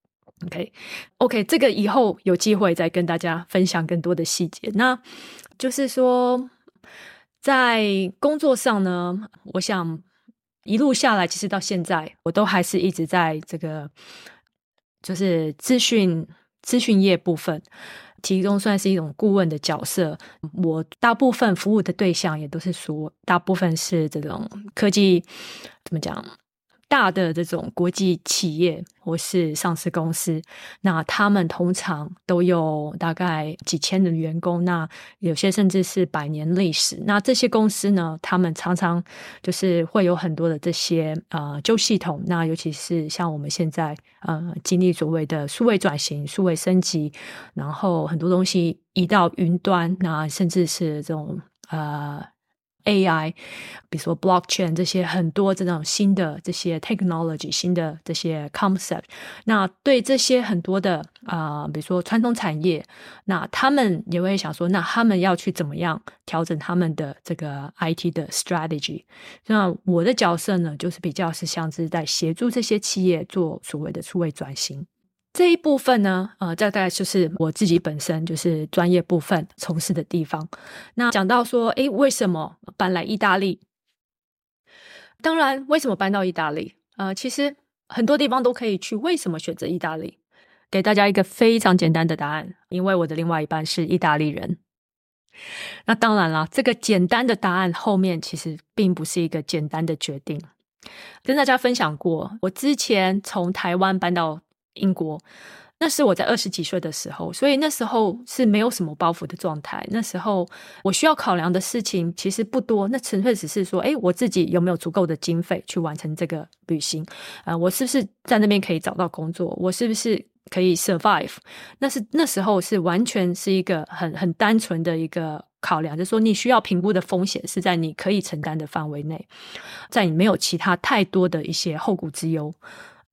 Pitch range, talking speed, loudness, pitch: 165-205 Hz, 275 characters per minute, -22 LUFS, 180 Hz